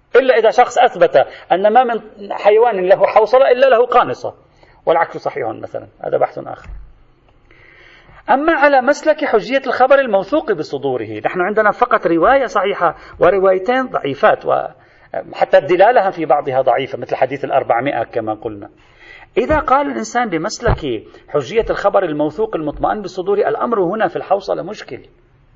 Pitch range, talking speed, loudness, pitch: 170-260 Hz, 135 wpm, -15 LUFS, 210 Hz